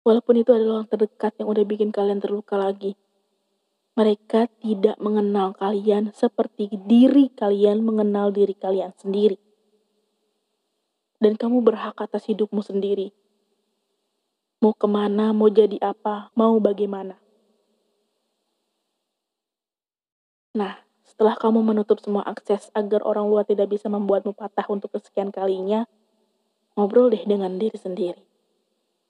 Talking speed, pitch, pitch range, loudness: 115 wpm, 210 Hz, 200-215 Hz, -22 LUFS